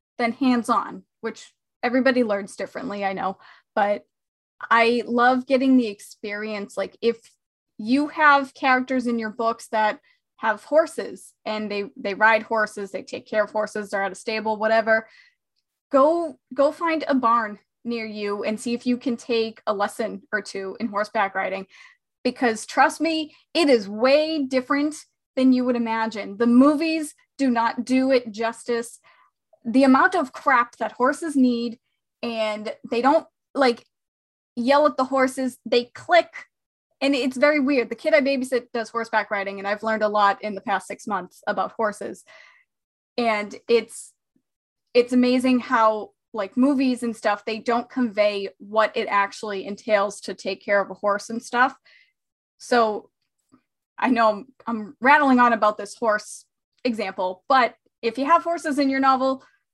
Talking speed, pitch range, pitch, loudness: 165 wpm, 215-265 Hz, 235 Hz, -22 LUFS